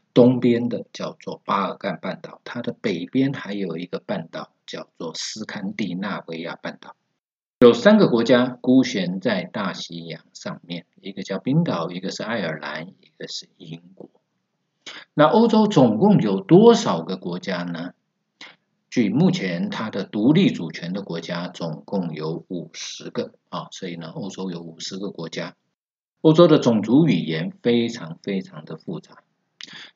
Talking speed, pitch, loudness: 230 characters per minute, 120 Hz, -21 LUFS